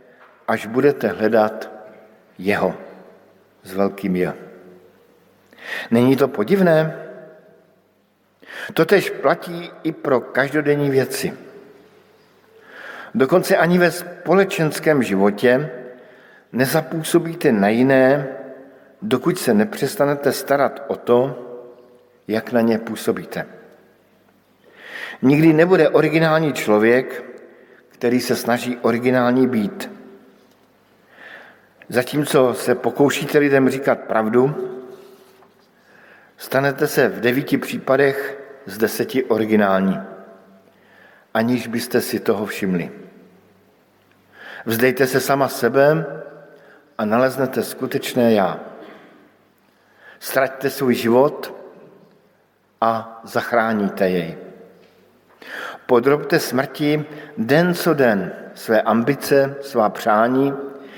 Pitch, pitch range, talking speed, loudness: 130 Hz, 115-150 Hz, 85 wpm, -18 LUFS